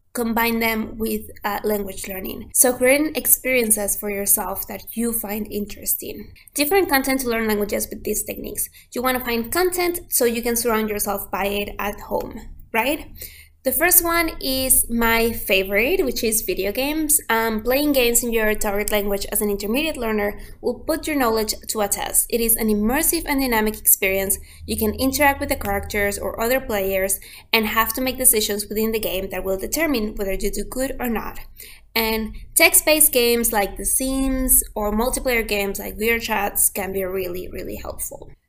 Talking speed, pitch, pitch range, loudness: 180 wpm, 225 Hz, 205-260 Hz, -20 LUFS